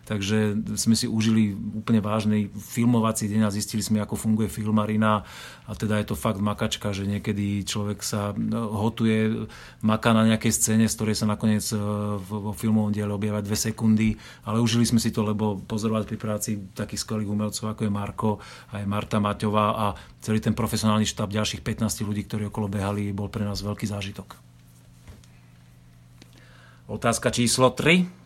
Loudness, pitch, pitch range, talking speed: -25 LUFS, 105 Hz, 105-110 Hz, 165 wpm